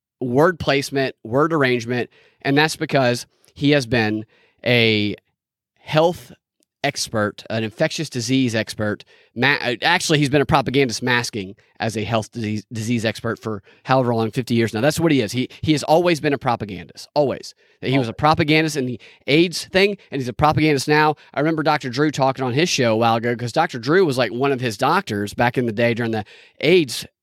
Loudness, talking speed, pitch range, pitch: -19 LUFS, 190 wpm, 115-150 Hz, 130 Hz